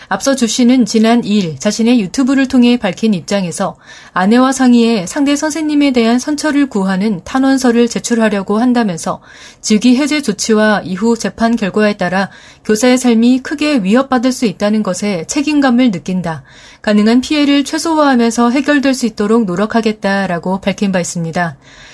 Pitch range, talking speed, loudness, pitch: 200-255 Hz, 355 characters per minute, -13 LUFS, 230 Hz